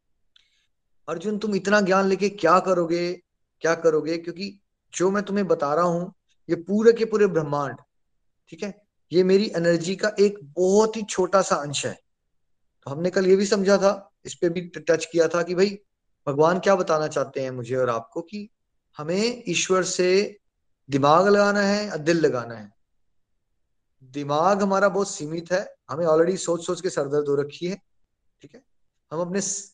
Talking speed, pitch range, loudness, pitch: 175 wpm, 150-195 Hz, -23 LUFS, 175 Hz